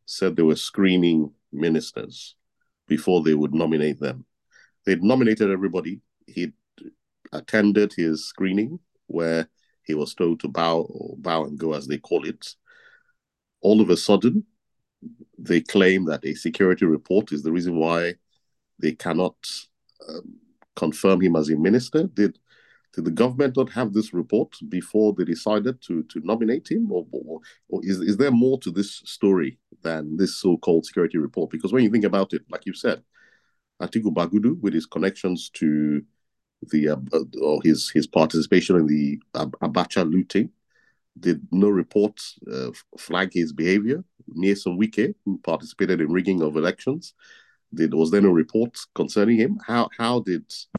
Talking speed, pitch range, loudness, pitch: 160 wpm, 80-110 Hz, -23 LUFS, 95 Hz